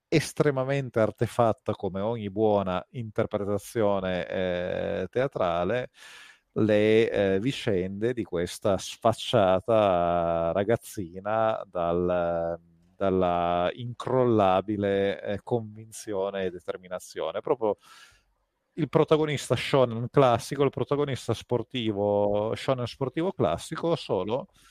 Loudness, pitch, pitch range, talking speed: -27 LUFS, 110 Hz, 95-125 Hz, 85 wpm